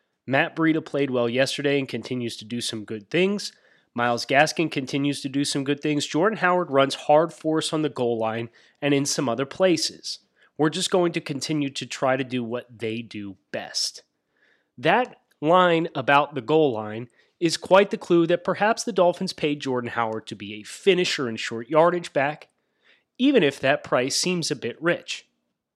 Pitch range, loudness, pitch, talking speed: 120-170 Hz, -23 LUFS, 145 Hz, 185 wpm